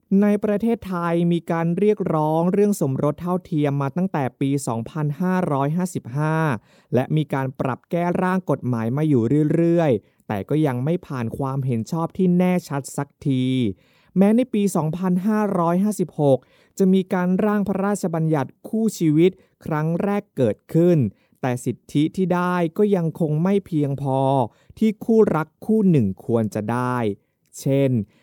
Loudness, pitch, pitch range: -21 LUFS, 160 Hz, 135-185 Hz